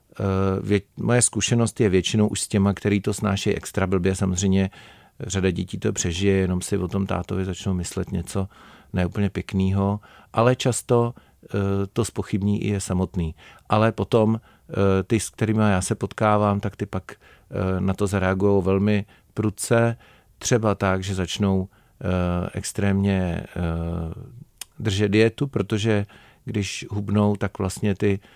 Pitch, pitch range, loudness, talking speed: 100 Hz, 95-110 Hz, -23 LUFS, 150 wpm